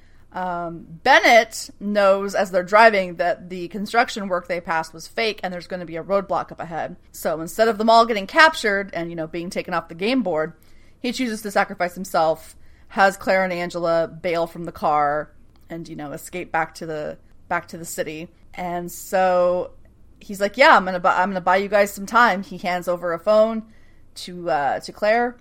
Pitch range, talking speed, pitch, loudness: 165-205 Hz, 205 wpm, 180 Hz, -20 LUFS